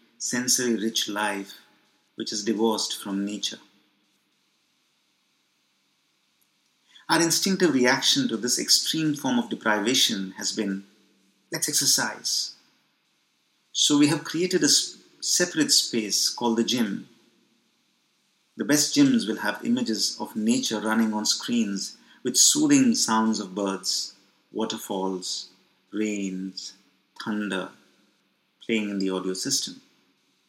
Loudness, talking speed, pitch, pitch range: -24 LUFS, 110 wpm, 110 Hz, 100-145 Hz